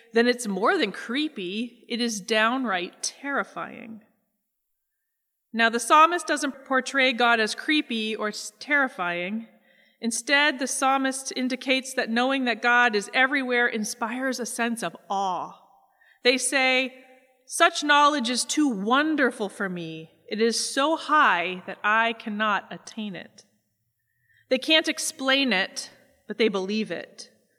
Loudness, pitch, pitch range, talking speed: -23 LUFS, 240 Hz, 215-265 Hz, 130 wpm